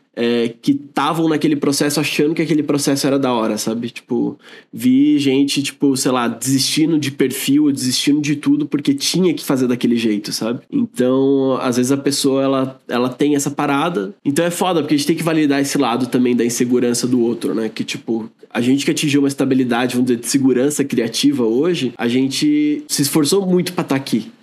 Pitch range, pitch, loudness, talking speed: 125-160 Hz, 140 Hz, -17 LUFS, 200 wpm